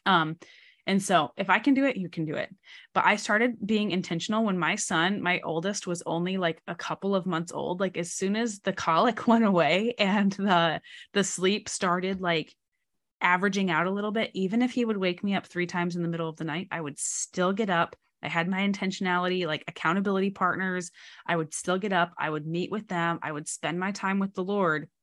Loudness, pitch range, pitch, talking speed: -27 LUFS, 170-200 Hz, 185 Hz, 225 wpm